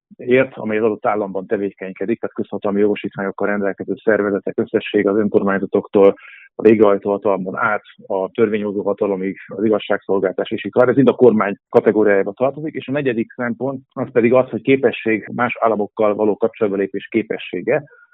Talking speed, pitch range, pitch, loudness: 140 wpm, 100-120 Hz, 105 Hz, -18 LUFS